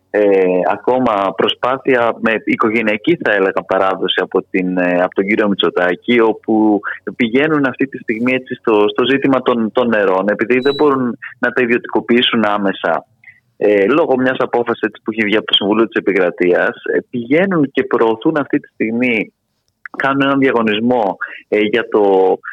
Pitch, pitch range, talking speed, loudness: 120 Hz, 105-130 Hz, 150 wpm, -15 LUFS